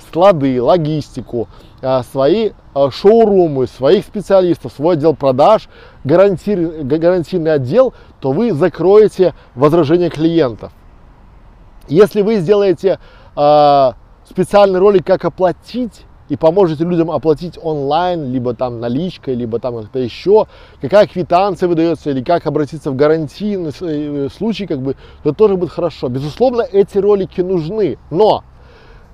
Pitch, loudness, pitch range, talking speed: 165 Hz, -14 LUFS, 140-190 Hz, 115 wpm